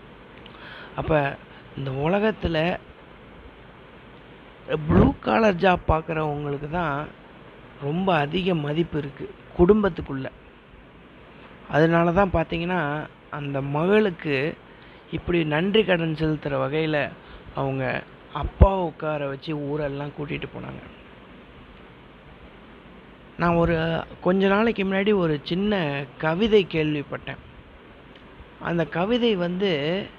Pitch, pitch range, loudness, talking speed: 160 Hz, 145-185 Hz, -24 LUFS, 85 wpm